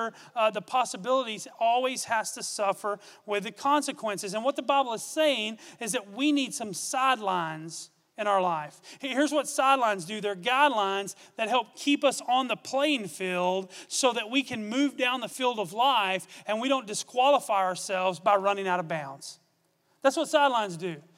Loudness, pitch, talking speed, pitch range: -27 LUFS, 220 Hz, 180 wpm, 190-260 Hz